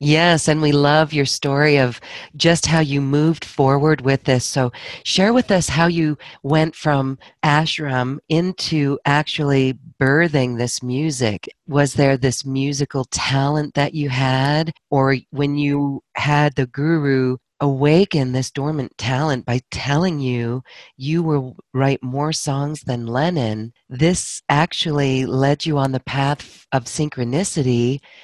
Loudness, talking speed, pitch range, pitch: -19 LUFS, 140 wpm, 130-155 Hz, 140 Hz